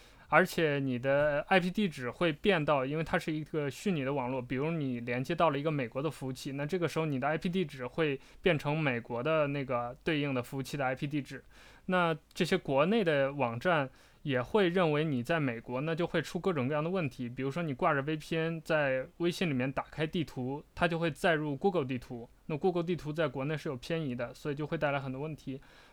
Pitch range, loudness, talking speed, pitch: 130-165 Hz, -32 LUFS, 350 characters per minute, 150 Hz